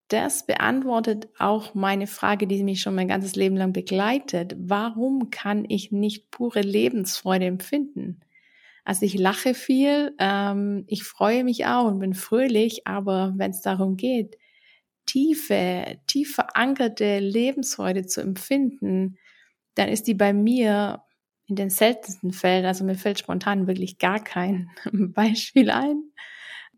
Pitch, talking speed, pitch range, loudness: 205 Hz, 135 wpm, 190-245 Hz, -24 LUFS